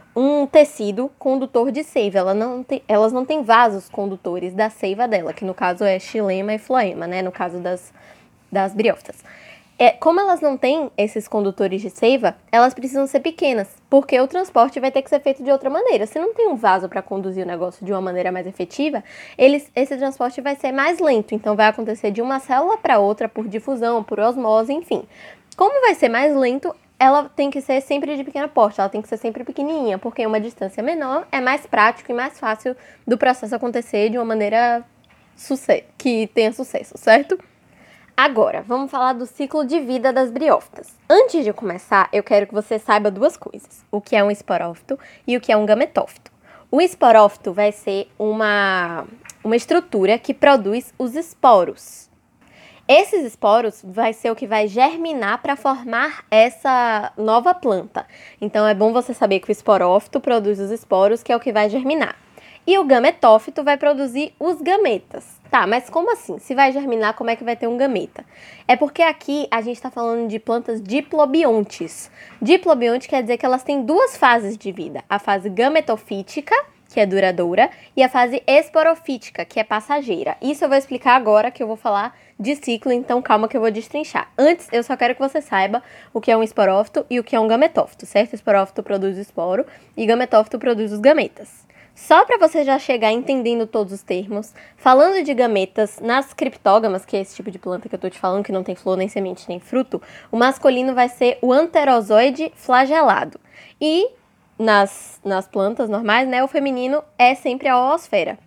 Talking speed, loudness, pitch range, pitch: 195 wpm, -18 LUFS, 210-280 Hz, 240 Hz